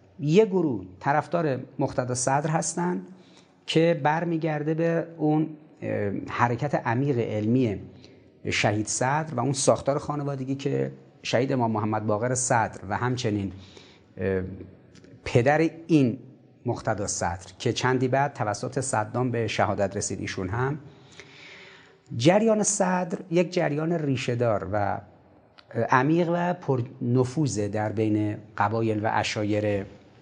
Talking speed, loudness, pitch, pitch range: 110 wpm, -26 LUFS, 130 Hz, 105-155 Hz